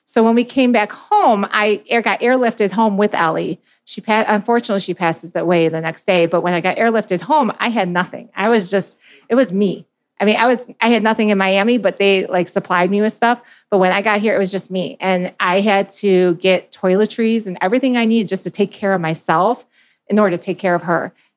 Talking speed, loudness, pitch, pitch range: 235 wpm, -16 LUFS, 200 Hz, 185-225 Hz